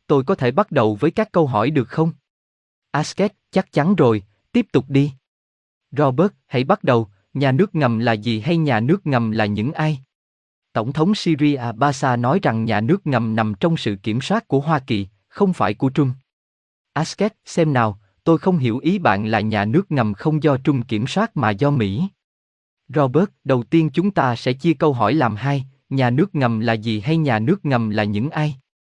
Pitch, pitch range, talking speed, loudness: 140 Hz, 110-160 Hz, 205 wpm, -19 LUFS